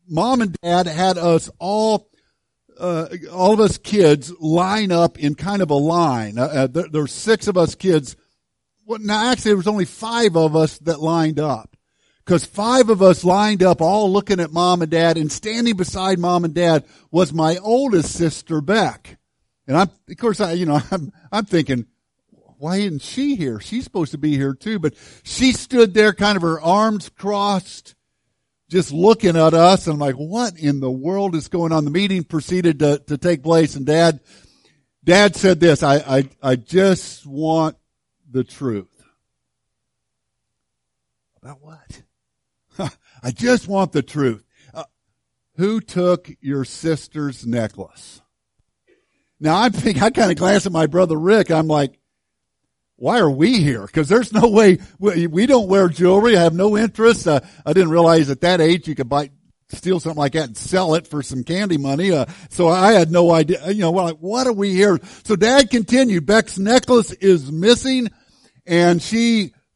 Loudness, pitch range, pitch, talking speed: -17 LUFS, 150-200 Hz, 175 Hz, 180 wpm